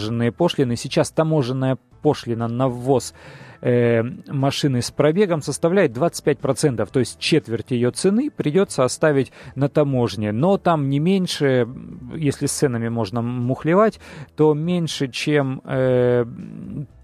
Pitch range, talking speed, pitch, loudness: 125-155 Hz, 125 wpm, 140 Hz, -20 LUFS